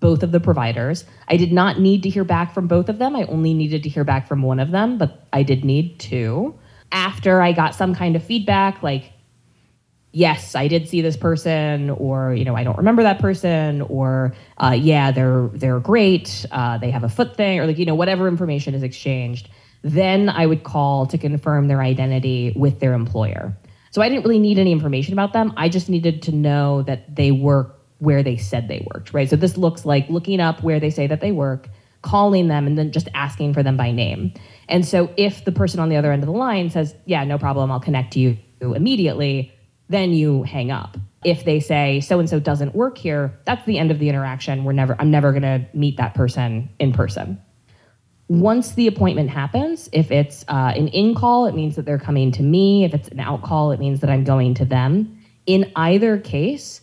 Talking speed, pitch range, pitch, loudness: 225 wpm, 130-175 Hz, 145 Hz, -19 LUFS